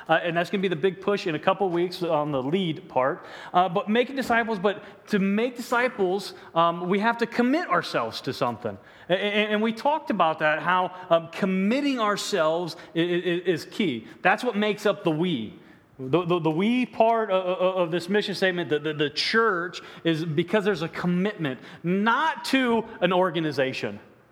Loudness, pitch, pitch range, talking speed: -25 LUFS, 185 Hz, 170-210 Hz, 190 wpm